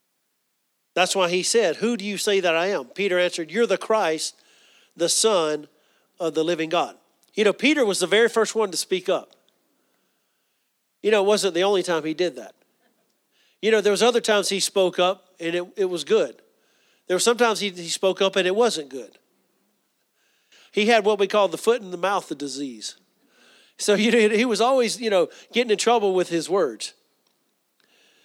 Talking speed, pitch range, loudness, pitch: 200 wpm, 175-220 Hz, -22 LUFS, 195 Hz